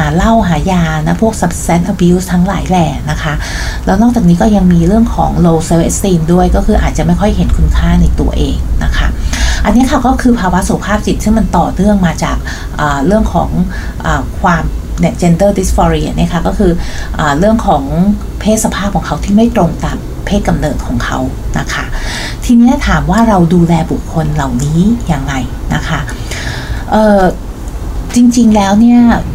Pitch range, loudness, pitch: 160-215 Hz, -11 LUFS, 180 Hz